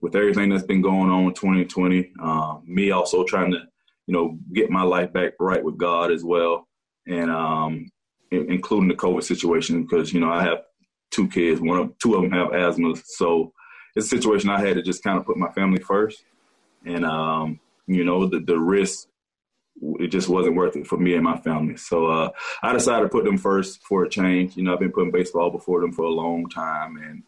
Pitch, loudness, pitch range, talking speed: 90 Hz, -22 LUFS, 80-95 Hz, 220 wpm